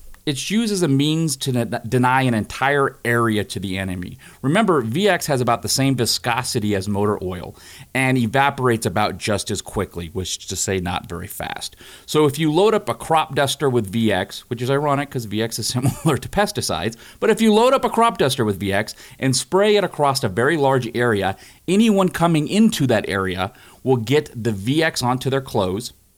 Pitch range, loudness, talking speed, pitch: 105-150 Hz, -20 LUFS, 195 wpm, 125 Hz